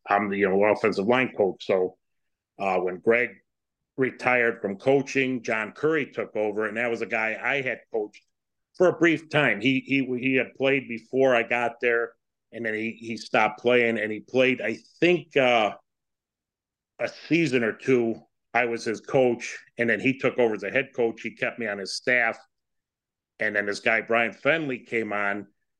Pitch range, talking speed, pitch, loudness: 110-130 Hz, 190 wpm, 115 Hz, -25 LUFS